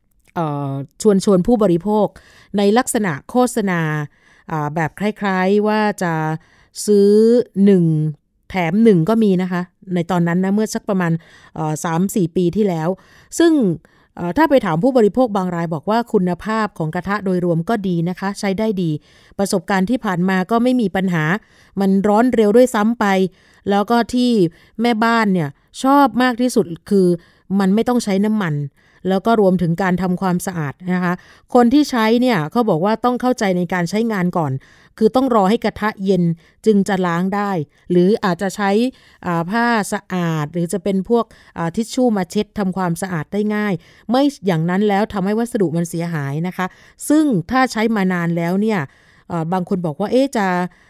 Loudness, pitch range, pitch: -17 LUFS, 175-220 Hz, 195 Hz